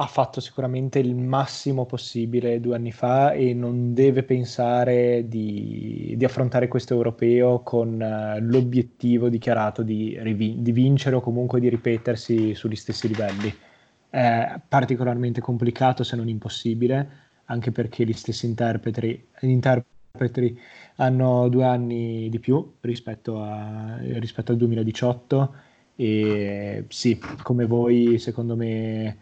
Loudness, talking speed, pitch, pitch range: -23 LUFS, 125 wpm, 120 Hz, 115-125 Hz